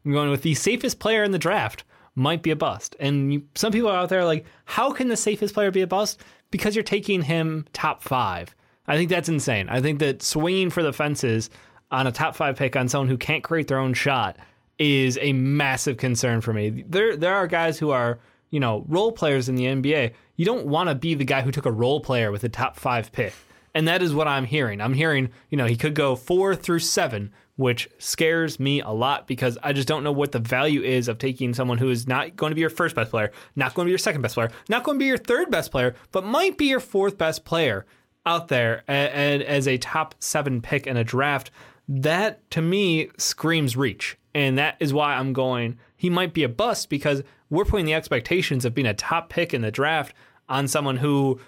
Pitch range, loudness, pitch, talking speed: 130-165 Hz, -23 LUFS, 145 Hz, 240 wpm